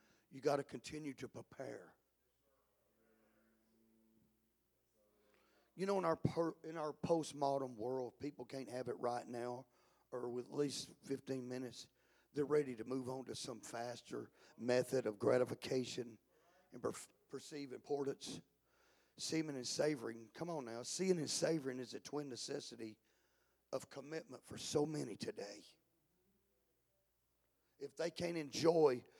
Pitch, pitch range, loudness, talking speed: 130 Hz, 115-145 Hz, -42 LUFS, 135 wpm